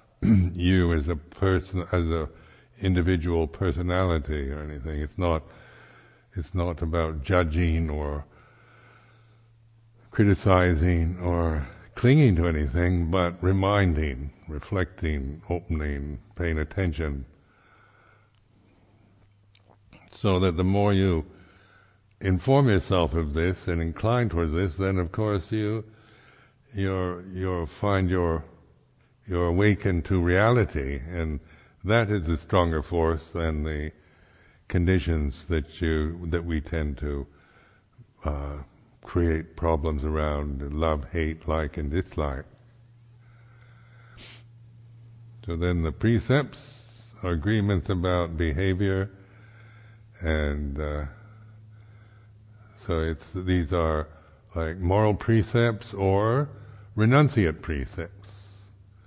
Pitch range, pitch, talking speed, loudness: 80-110 Hz, 90 Hz, 100 wpm, -26 LUFS